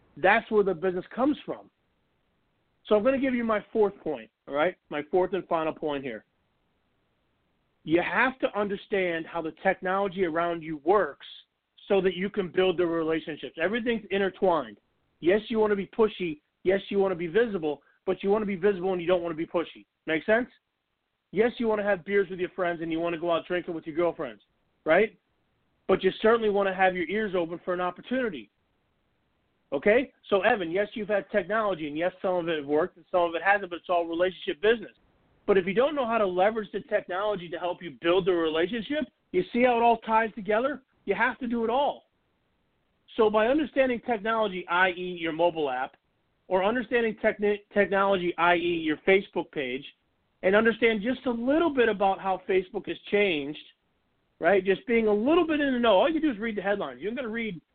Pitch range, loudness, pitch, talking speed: 175-225 Hz, -27 LUFS, 195 Hz, 210 wpm